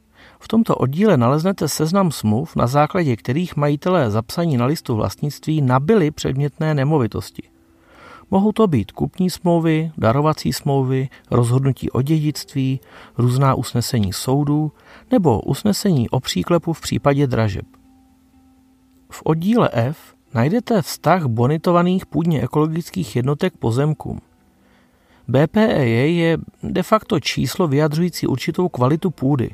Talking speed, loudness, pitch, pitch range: 115 wpm, -19 LUFS, 150 Hz, 125-175 Hz